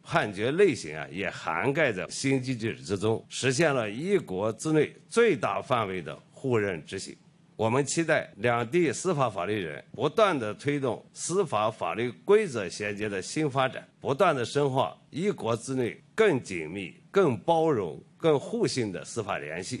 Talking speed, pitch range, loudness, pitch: 245 characters per minute, 110-170 Hz, -28 LUFS, 135 Hz